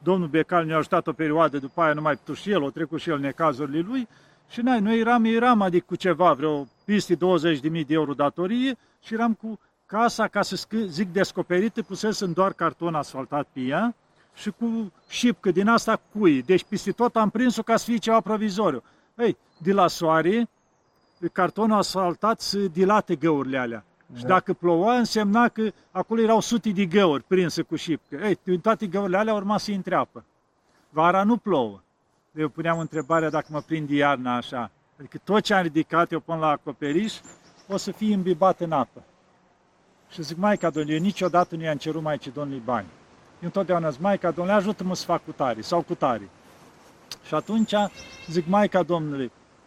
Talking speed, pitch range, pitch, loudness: 185 wpm, 160-210 Hz, 180 Hz, -24 LUFS